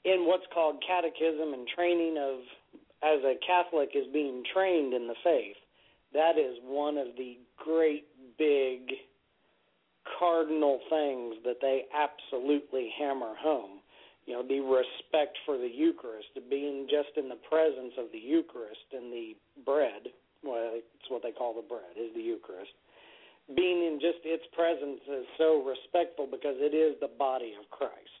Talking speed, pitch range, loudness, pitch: 155 wpm, 130-170 Hz, -31 LUFS, 150 Hz